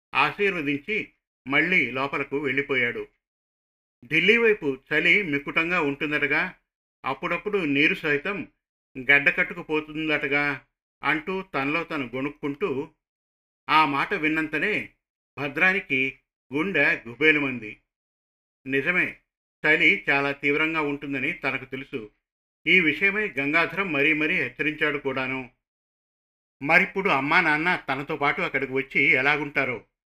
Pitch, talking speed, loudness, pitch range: 145 Hz, 90 wpm, -23 LUFS, 135-160 Hz